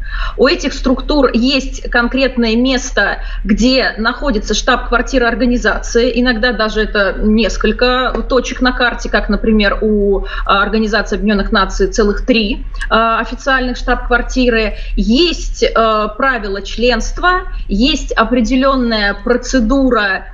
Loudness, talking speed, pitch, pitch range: -13 LUFS, 95 wpm, 240 Hz, 220-255 Hz